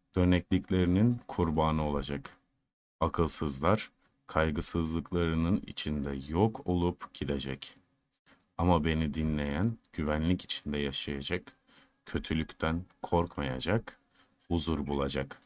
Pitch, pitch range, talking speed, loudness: 80 Hz, 75-90 Hz, 75 wpm, -32 LUFS